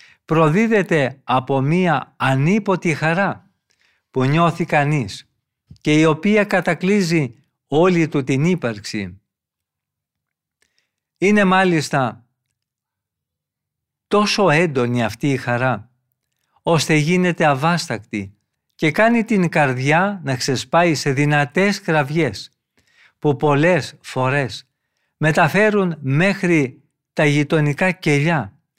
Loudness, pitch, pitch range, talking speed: -18 LUFS, 150 Hz, 130-175 Hz, 90 wpm